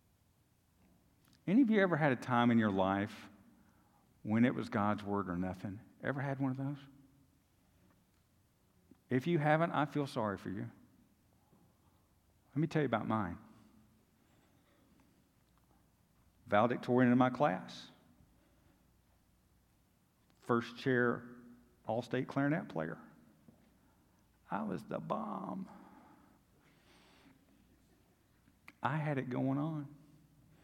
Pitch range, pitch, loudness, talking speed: 95-140 Hz, 120 Hz, -35 LUFS, 105 wpm